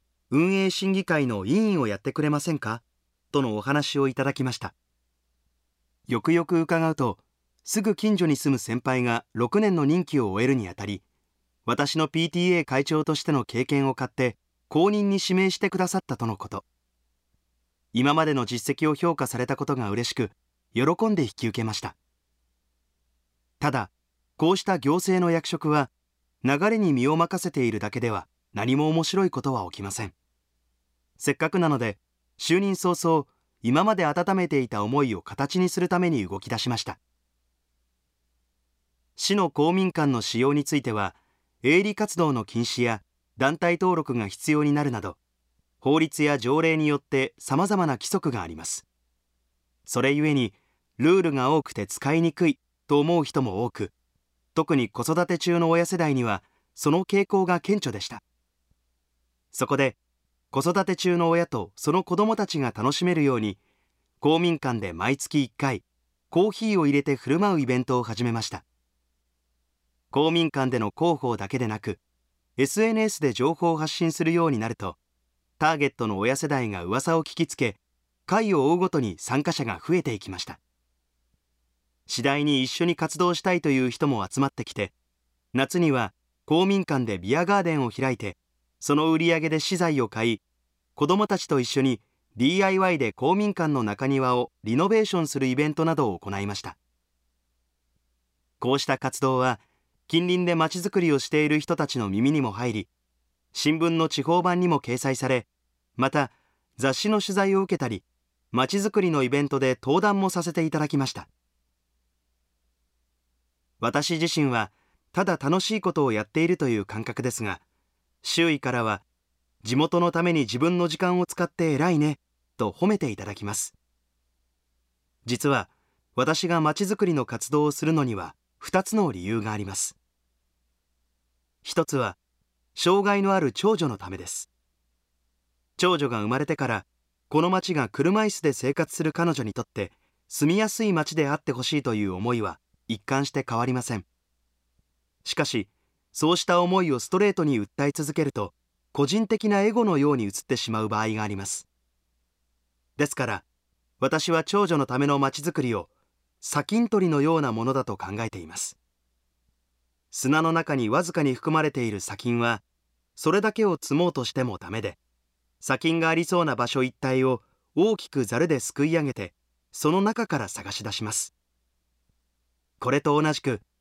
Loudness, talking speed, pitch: -25 LUFS, 305 characters per minute, 130 Hz